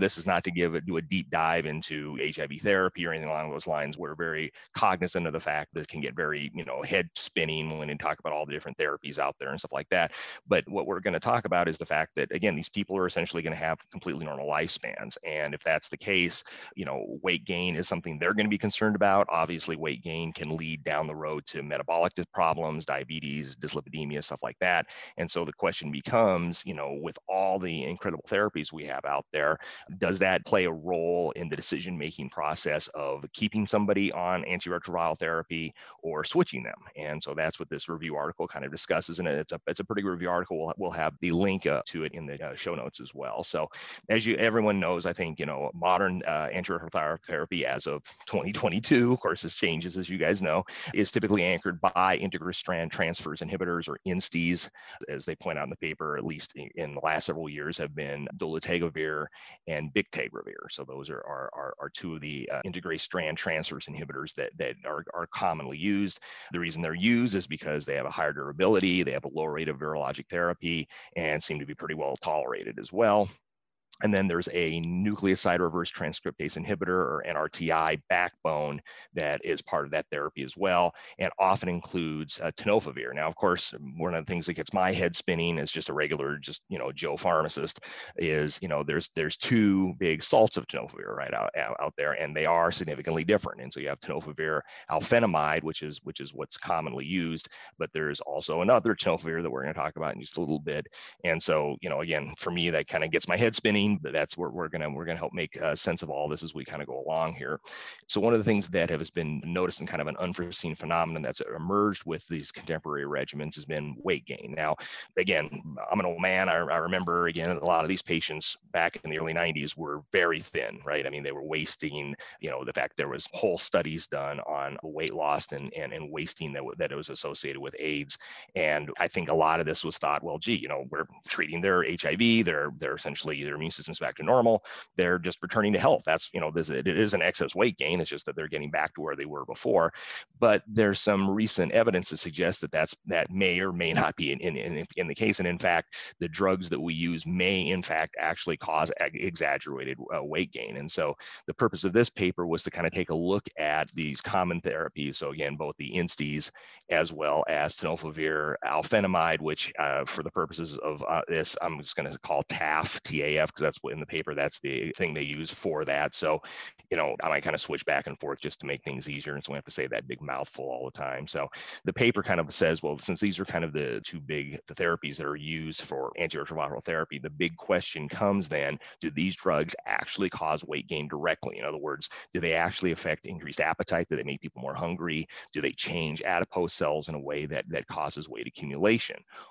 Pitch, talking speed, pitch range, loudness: 85 Hz, 225 wpm, 75-90 Hz, -30 LUFS